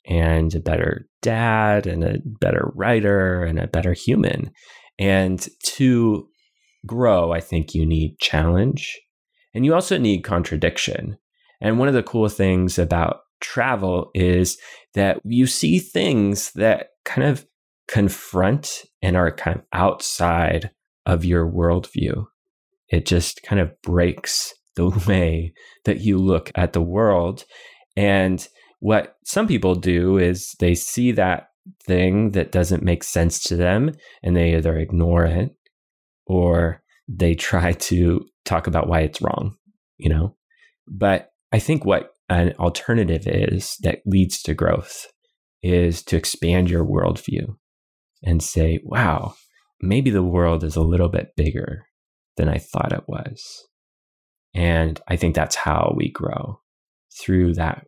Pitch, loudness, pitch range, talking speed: 90 Hz, -20 LUFS, 85-105 Hz, 140 wpm